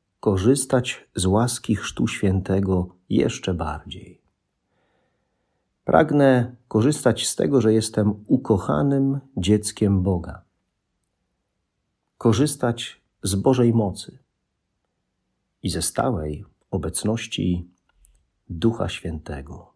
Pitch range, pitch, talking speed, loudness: 90-120 Hz, 100 Hz, 80 wpm, -22 LUFS